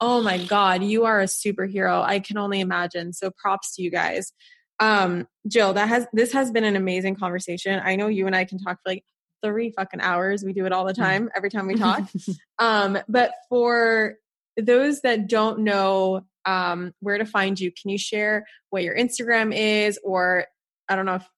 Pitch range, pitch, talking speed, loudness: 190-220 Hz, 195 Hz, 200 wpm, -23 LUFS